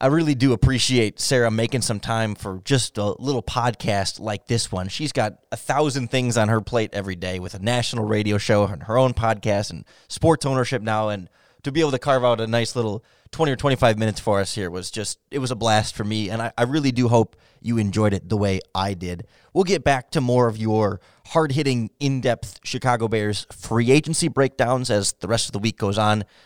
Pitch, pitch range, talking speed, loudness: 115 Hz, 105-130 Hz, 230 wpm, -22 LUFS